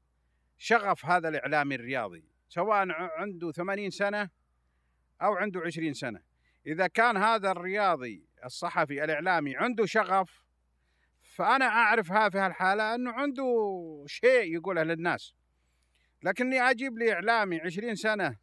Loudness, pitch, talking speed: -28 LUFS, 180 Hz, 115 wpm